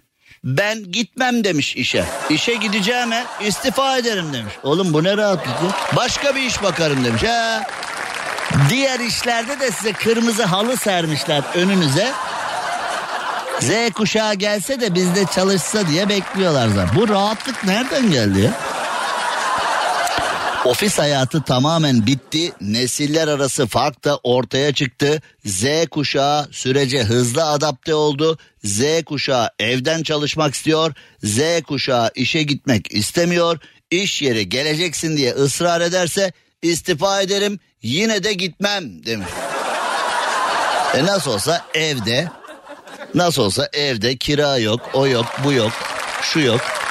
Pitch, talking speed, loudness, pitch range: 160 Hz, 120 wpm, -18 LUFS, 135-200 Hz